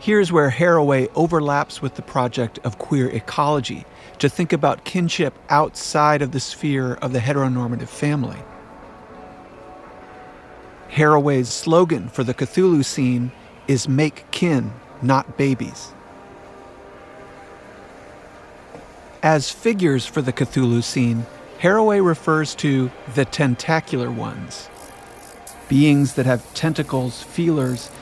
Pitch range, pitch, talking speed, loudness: 130-155 Hz, 140 Hz, 105 wpm, -20 LUFS